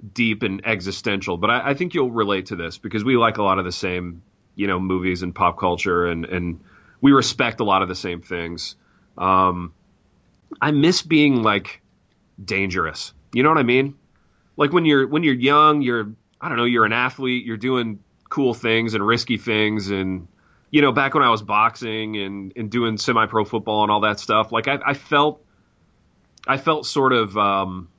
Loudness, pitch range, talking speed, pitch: -20 LUFS, 95-130 Hz, 195 wpm, 110 Hz